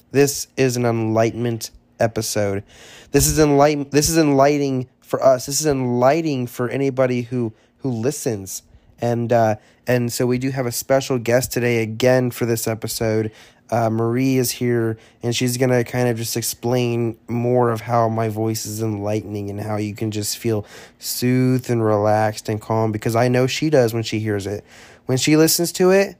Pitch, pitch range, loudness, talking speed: 120 Hz, 110-130 Hz, -20 LUFS, 185 wpm